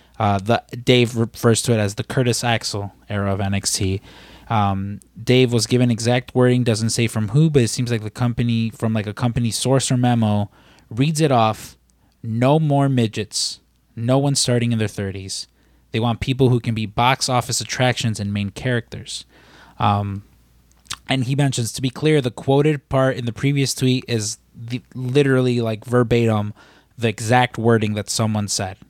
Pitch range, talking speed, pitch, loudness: 105-125 Hz, 175 wpm, 115 Hz, -19 LUFS